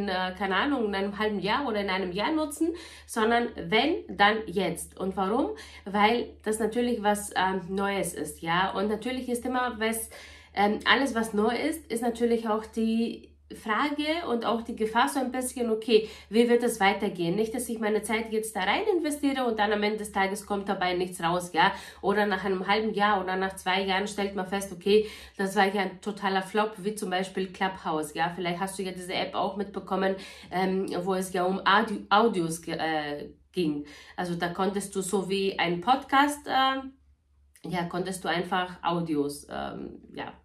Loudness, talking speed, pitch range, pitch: -28 LUFS, 195 wpm, 185-225 Hz, 200 Hz